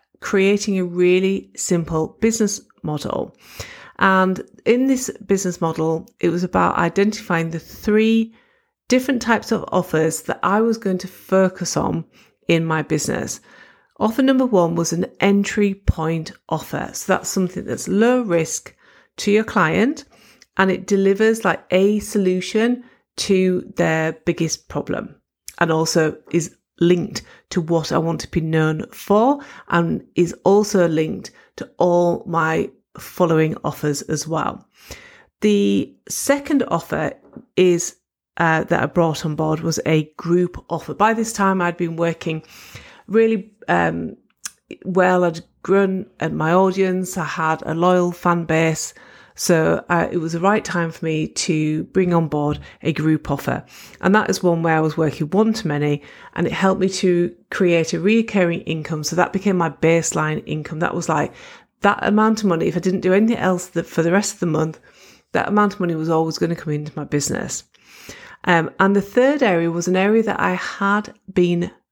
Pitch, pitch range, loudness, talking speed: 180 Hz, 160-205 Hz, -19 LUFS, 170 wpm